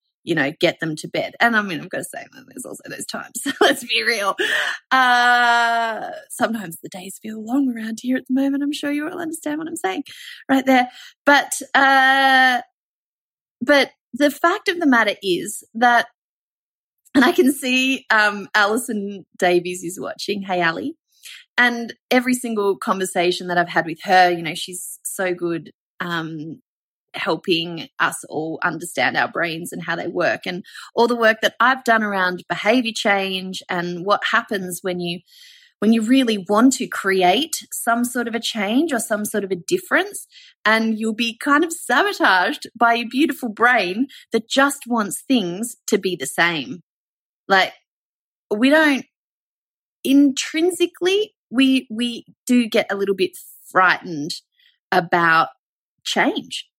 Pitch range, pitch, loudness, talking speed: 190-280 Hz, 235 Hz, -19 LUFS, 160 wpm